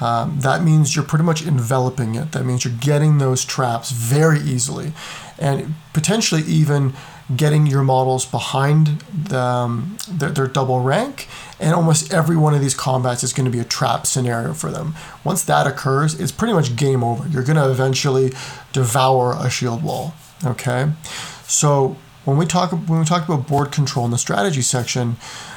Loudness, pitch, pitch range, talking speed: -18 LUFS, 140 Hz, 130-160 Hz, 180 wpm